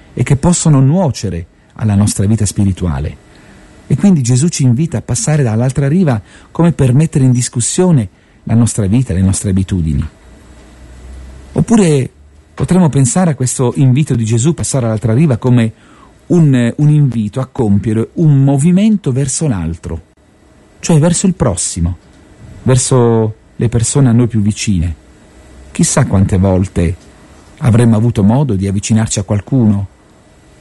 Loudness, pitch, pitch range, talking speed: -12 LUFS, 115 Hz, 95-140 Hz, 135 wpm